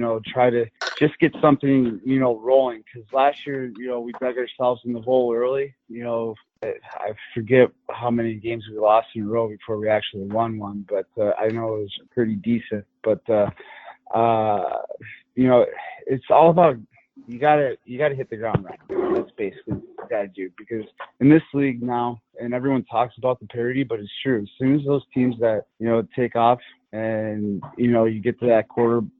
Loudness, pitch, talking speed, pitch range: -22 LUFS, 120 Hz, 200 wpm, 115-135 Hz